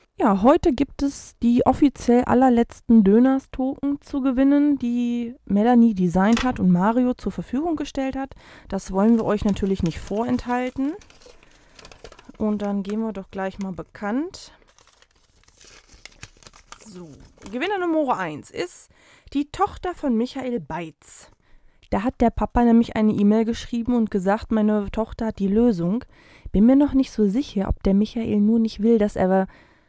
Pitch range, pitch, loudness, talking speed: 205-265 Hz, 230 Hz, -21 LUFS, 150 wpm